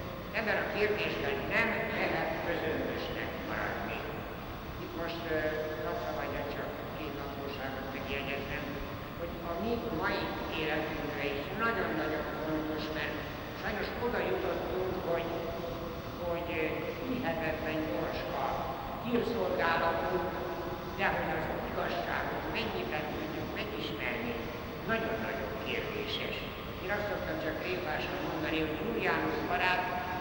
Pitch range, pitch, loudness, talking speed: 150-175 Hz, 165 Hz, -34 LUFS, 100 wpm